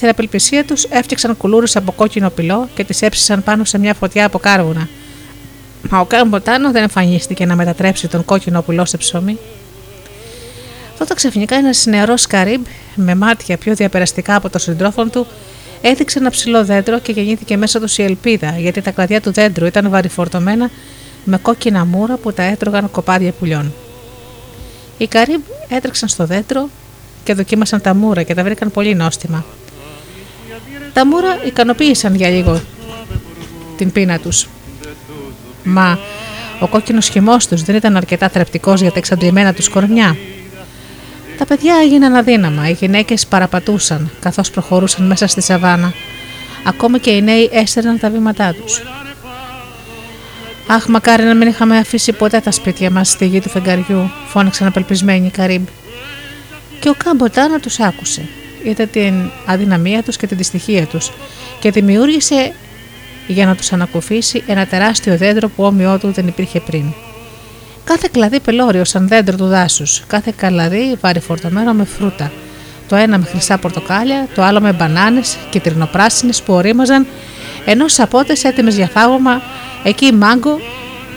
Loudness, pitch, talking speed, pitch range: -12 LUFS, 195 Hz, 150 wpm, 175-225 Hz